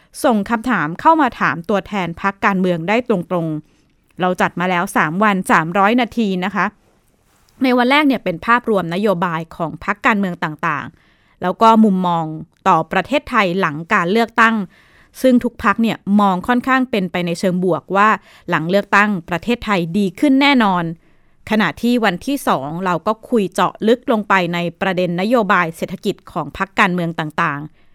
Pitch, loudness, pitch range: 195 Hz, -16 LUFS, 175-225 Hz